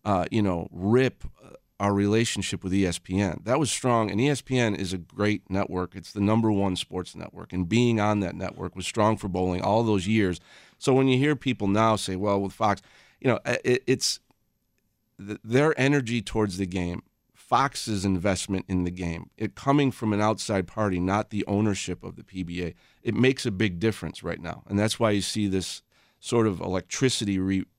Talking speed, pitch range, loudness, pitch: 190 wpm, 95-115 Hz, -26 LUFS, 105 Hz